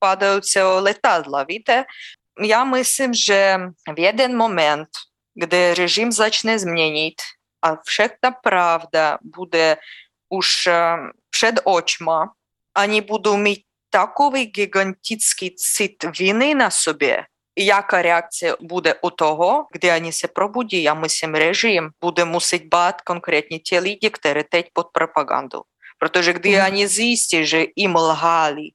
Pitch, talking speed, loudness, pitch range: 180 Hz, 125 wpm, -18 LUFS, 165-210 Hz